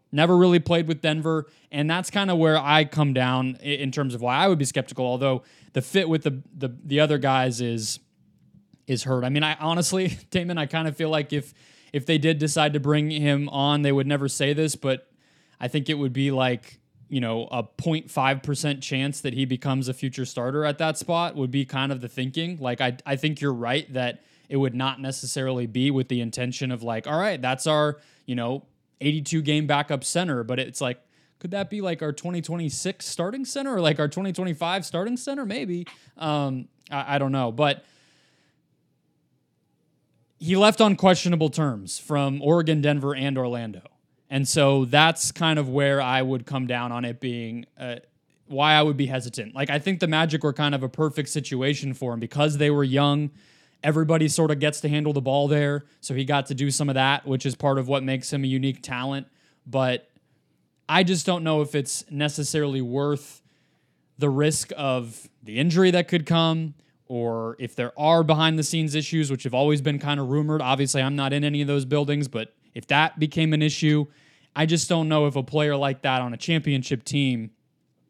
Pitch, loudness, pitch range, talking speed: 145 Hz, -24 LUFS, 130-155 Hz, 205 wpm